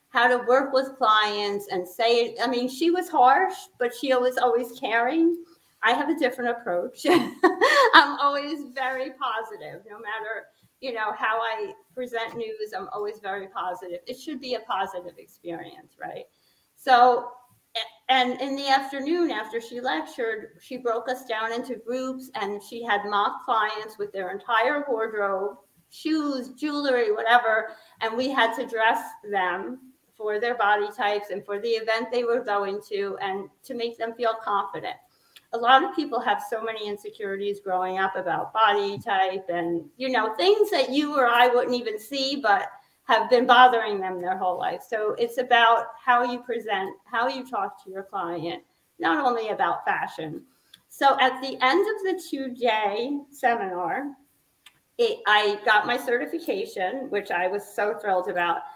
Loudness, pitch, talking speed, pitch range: -24 LUFS, 235 Hz, 165 wpm, 210-265 Hz